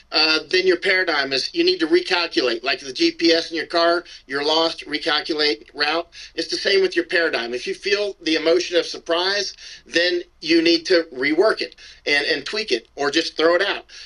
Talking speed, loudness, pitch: 200 wpm, -20 LUFS, 175 Hz